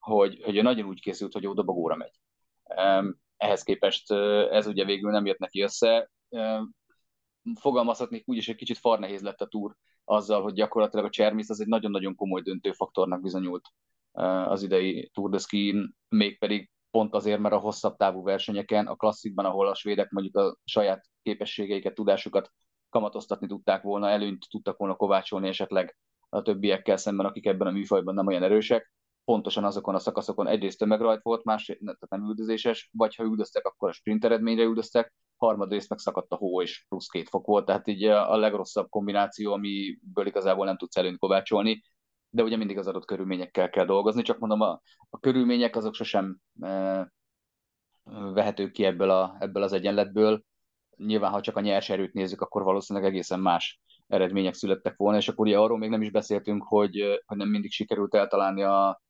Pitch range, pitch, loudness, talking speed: 95-110 Hz, 105 Hz, -27 LUFS, 175 wpm